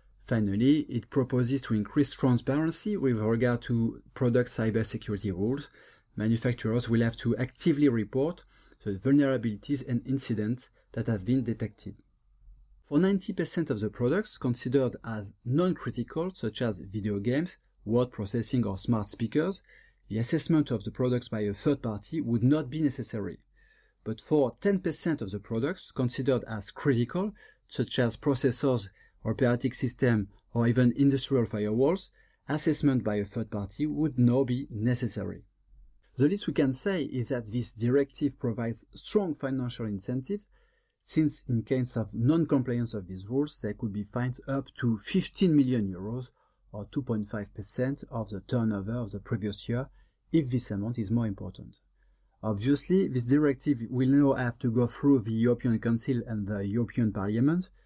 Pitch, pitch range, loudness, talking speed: 125 Hz, 110-140 Hz, -29 LUFS, 150 wpm